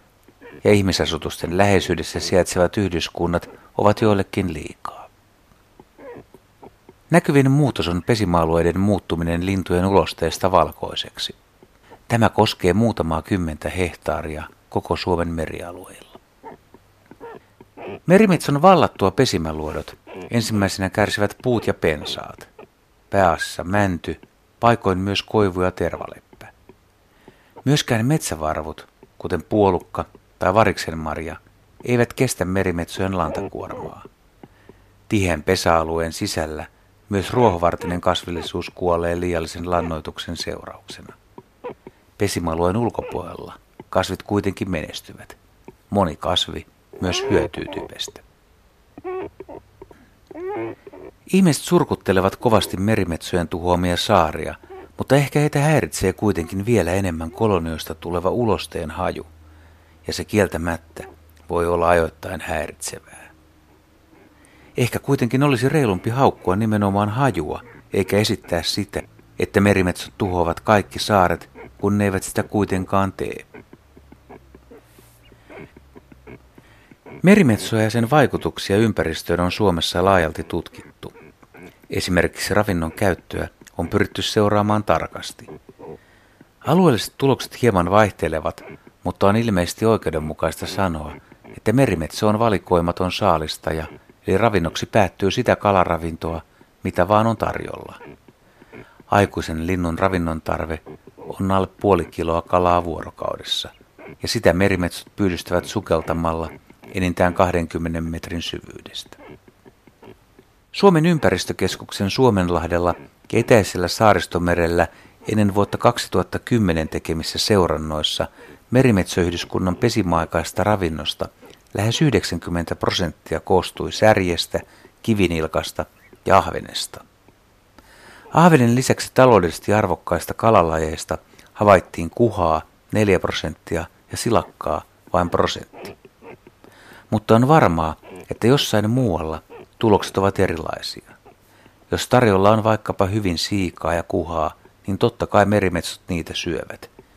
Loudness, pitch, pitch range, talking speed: -20 LUFS, 95 Hz, 85-110 Hz, 95 wpm